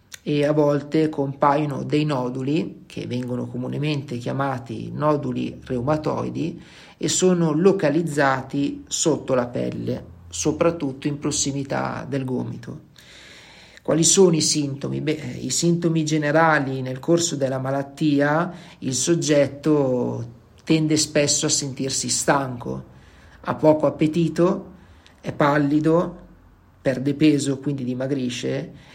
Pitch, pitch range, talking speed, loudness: 145 Hz, 130-155 Hz, 105 wpm, -22 LUFS